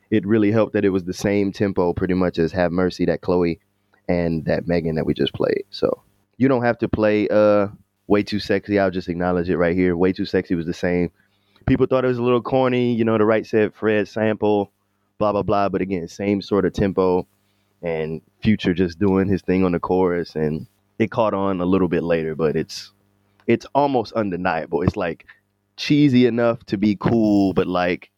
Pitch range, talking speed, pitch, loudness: 90-105 Hz, 210 wpm, 100 Hz, -20 LUFS